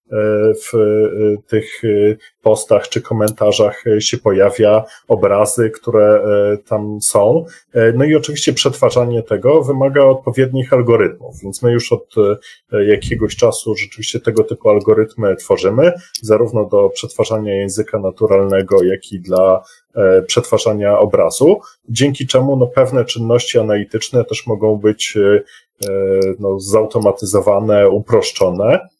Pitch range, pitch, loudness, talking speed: 105-130 Hz, 110 Hz, -14 LUFS, 105 wpm